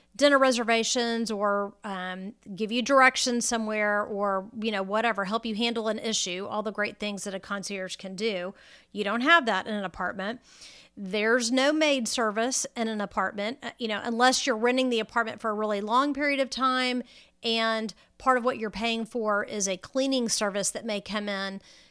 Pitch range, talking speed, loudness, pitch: 205-245 Hz, 190 wpm, -27 LUFS, 220 Hz